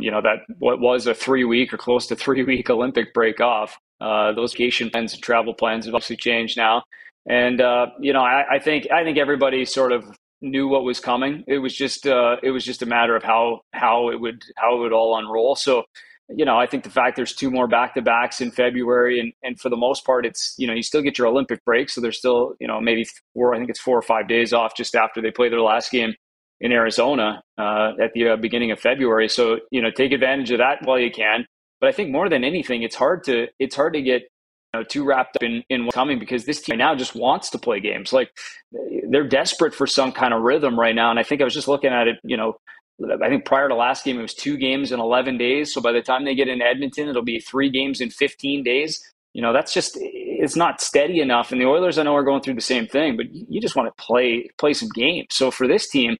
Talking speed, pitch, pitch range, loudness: 260 wpm, 125 Hz, 115-135 Hz, -20 LUFS